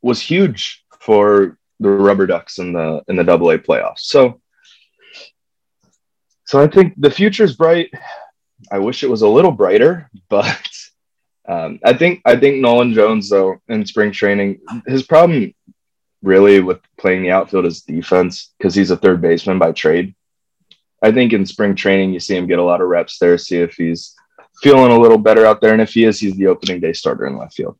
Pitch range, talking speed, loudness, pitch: 95-140 Hz, 195 wpm, -13 LUFS, 105 Hz